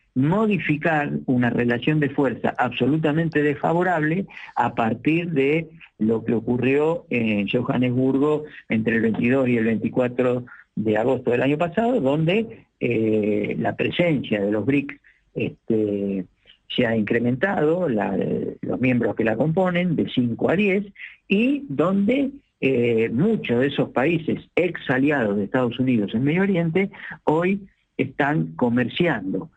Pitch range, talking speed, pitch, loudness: 120-165 Hz, 130 wpm, 135 Hz, -22 LUFS